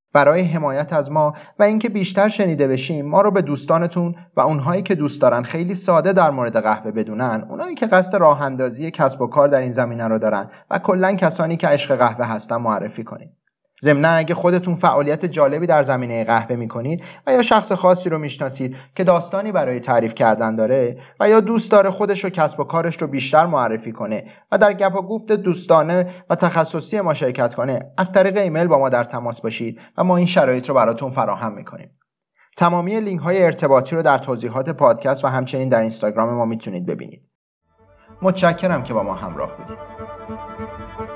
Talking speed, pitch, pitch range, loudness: 190 wpm, 155 Hz, 125-185 Hz, -18 LUFS